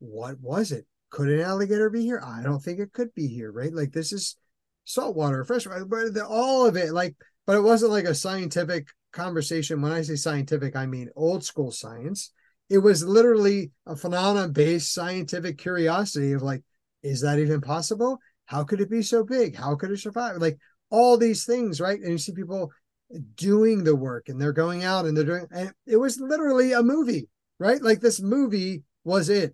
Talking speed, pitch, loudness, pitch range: 195 wpm, 180 Hz, -24 LUFS, 155-220 Hz